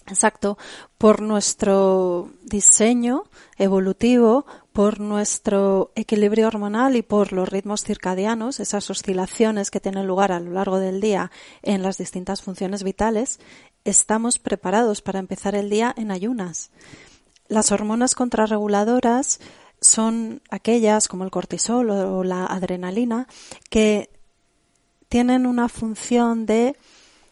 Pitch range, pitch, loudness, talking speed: 195-230 Hz, 210 Hz, -20 LUFS, 115 wpm